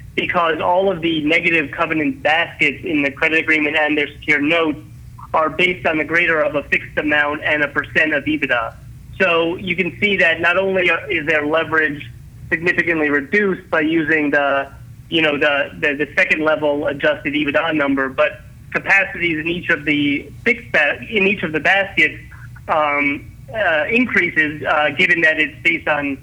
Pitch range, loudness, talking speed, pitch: 145-175 Hz, -16 LUFS, 175 wpm, 155 Hz